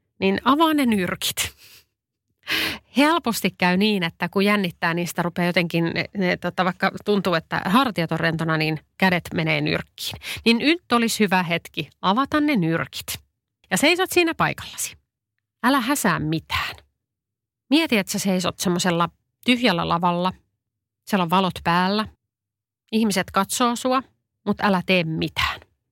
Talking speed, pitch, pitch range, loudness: 135 wpm, 185 Hz, 165-220 Hz, -22 LUFS